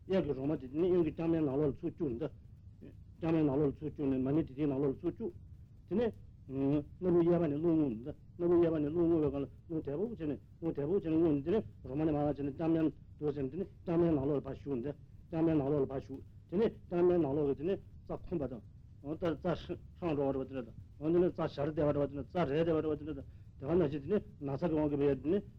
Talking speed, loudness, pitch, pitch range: 190 wpm, -34 LUFS, 150 Hz, 135-165 Hz